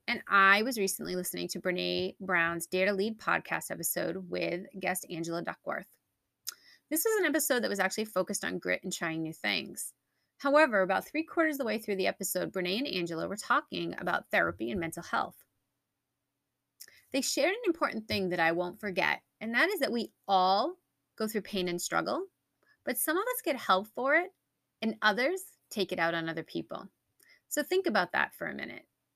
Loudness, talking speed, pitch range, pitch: -31 LUFS, 195 wpm, 180-290 Hz, 200 Hz